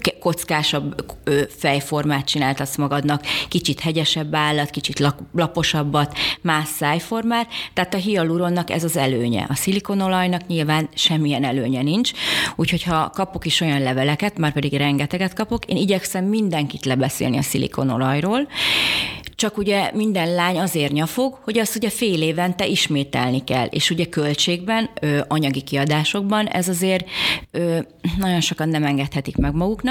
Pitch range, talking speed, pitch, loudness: 145-190 Hz, 135 wpm, 160 Hz, -20 LUFS